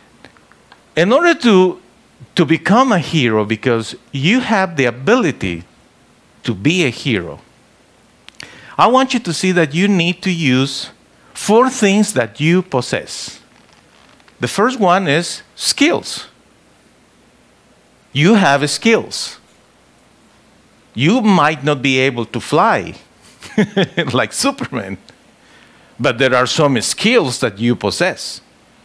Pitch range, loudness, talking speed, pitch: 125-200 Hz, -15 LUFS, 115 wpm, 155 Hz